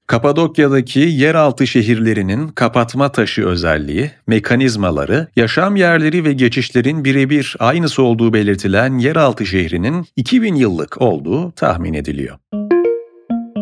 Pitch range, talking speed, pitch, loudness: 110-150 Hz, 95 wpm, 130 Hz, -14 LUFS